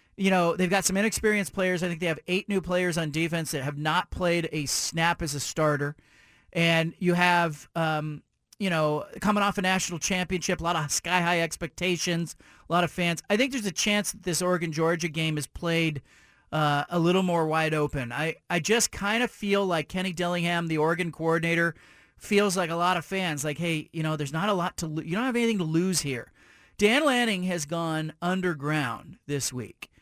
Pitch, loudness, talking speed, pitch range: 170 Hz, -26 LUFS, 210 wpm, 160-185 Hz